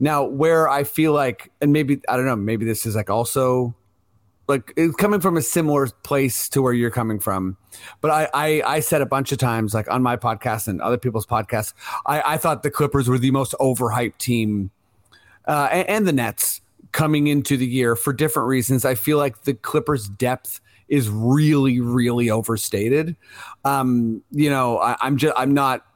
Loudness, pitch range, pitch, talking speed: -20 LUFS, 115-145 Hz, 130 Hz, 195 wpm